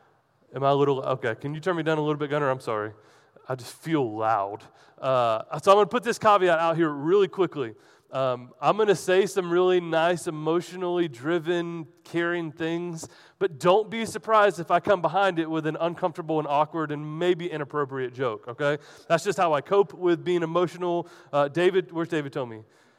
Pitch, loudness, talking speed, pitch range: 165 Hz, -25 LUFS, 200 wpm, 145-180 Hz